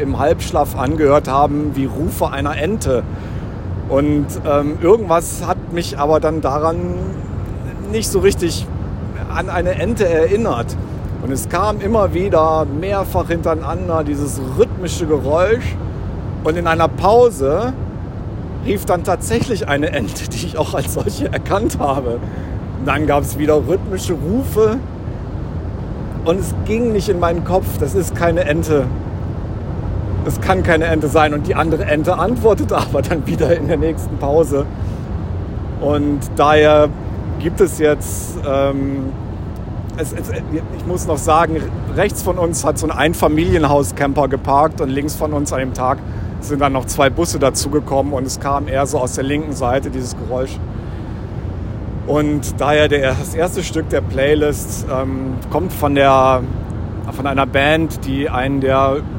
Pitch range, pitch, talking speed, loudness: 100-145 Hz, 130 Hz, 150 wpm, -17 LUFS